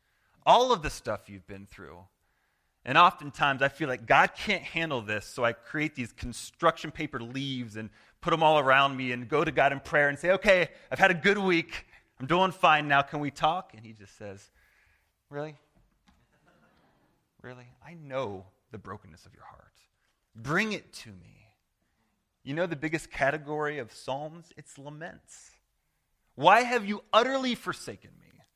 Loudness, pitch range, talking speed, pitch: -27 LUFS, 110-165 Hz, 170 wpm, 140 Hz